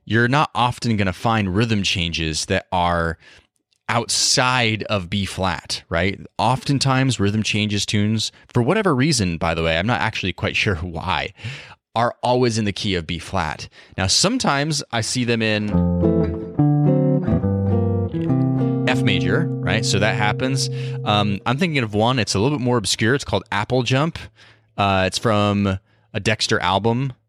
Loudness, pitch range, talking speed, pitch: -20 LUFS, 95-125 Hz, 155 wpm, 110 Hz